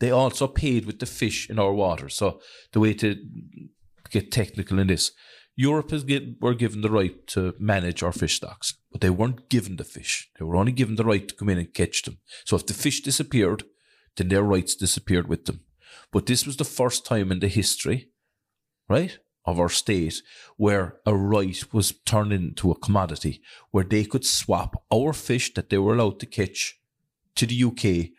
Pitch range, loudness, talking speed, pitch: 95-120 Hz, -24 LUFS, 200 wpm, 105 Hz